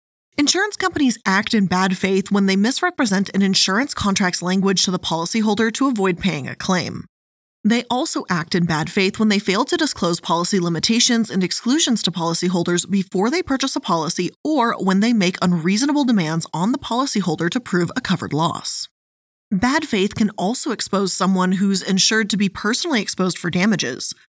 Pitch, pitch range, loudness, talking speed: 195 Hz, 180-235 Hz, -19 LUFS, 175 wpm